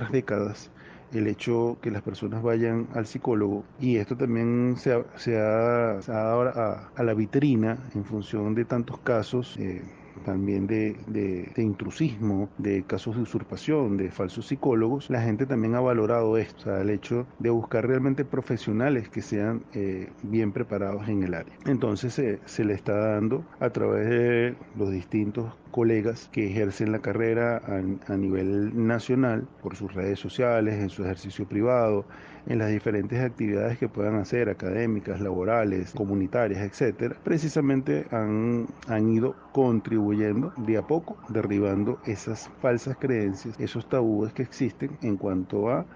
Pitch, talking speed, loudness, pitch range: 110 Hz, 155 wpm, -27 LUFS, 100-120 Hz